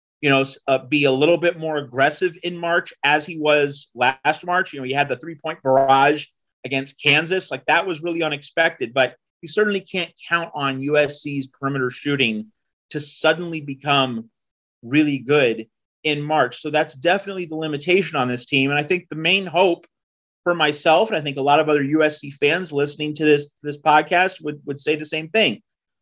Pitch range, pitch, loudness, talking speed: 140-170 Hz, 150 Hz, -20 LUFS, 190 wpm